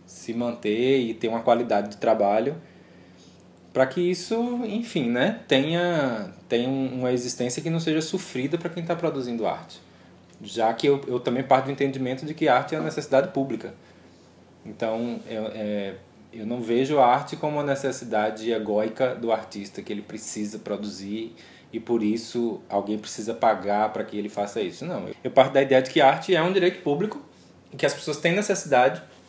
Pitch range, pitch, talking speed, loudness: 105-140 Hz, 120 Hz, 180 wpm, -25 LUFS